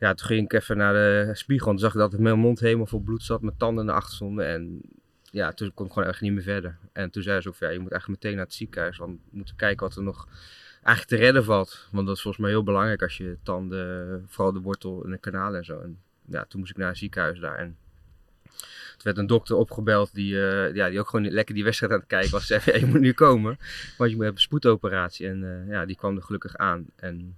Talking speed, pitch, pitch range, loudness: 275 wpm, 100 Hz, 95-110 Hz, -25 LUFS